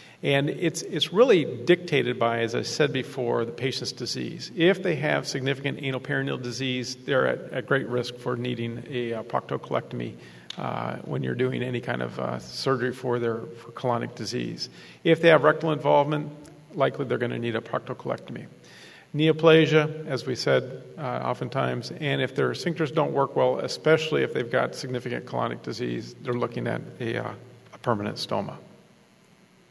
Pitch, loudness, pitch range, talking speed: 135 Hz, -26 LUFS, 120-155 Hz, 165 wpm